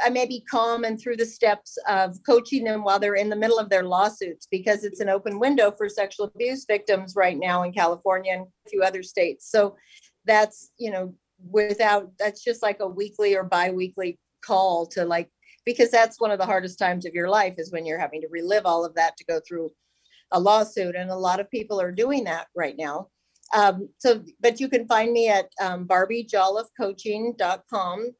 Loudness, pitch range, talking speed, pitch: -24 LUFS, 185-225 Hz, 205 wpm, 200 Hz